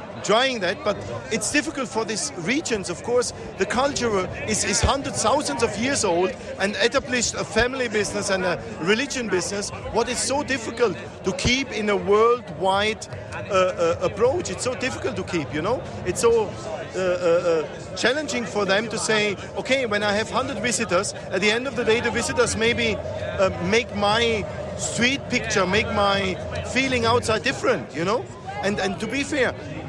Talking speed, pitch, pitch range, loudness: 175 wpm, 220 Hz, 190-245 Hz, -23 LUFS